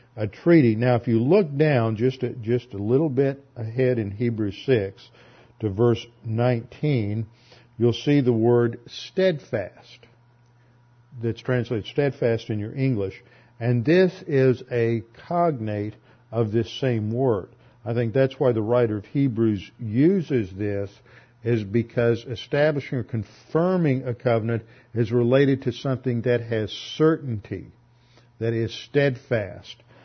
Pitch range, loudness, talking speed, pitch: 115-130 Hz, -23 LUFS, 135 wpm, 120 Hz